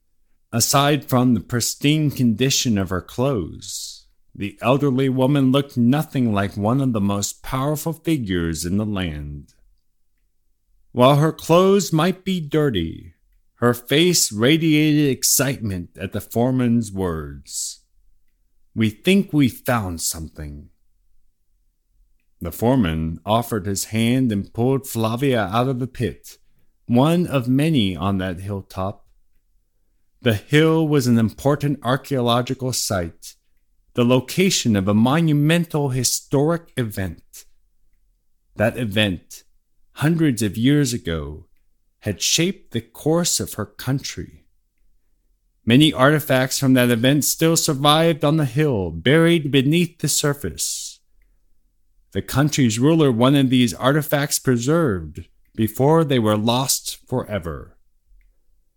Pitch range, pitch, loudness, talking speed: 100-145 Hz, 125 Hz, -19 LUFS, 115 wpm